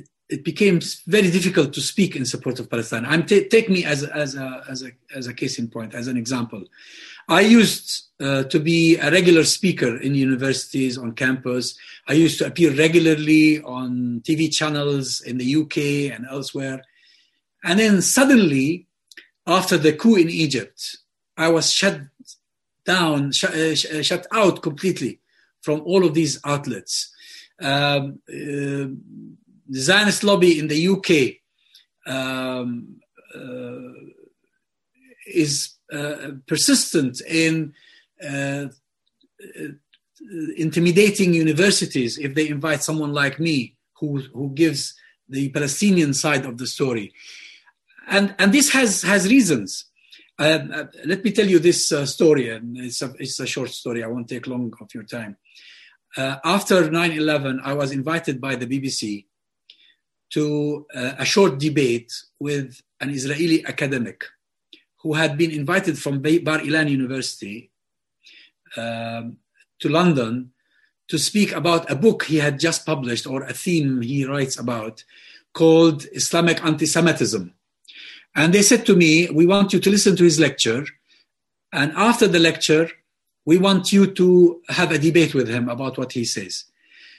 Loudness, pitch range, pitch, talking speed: -19 LUFS, 130-175 Hz, 155 Hz, 145 wpm